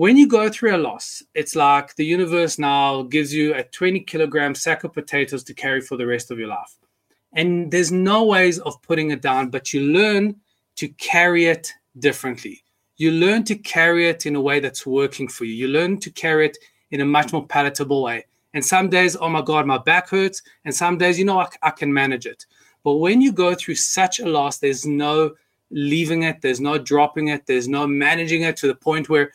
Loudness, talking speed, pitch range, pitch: -19 LUFS, 220 wpm, 140-175 Hz, 155 Hz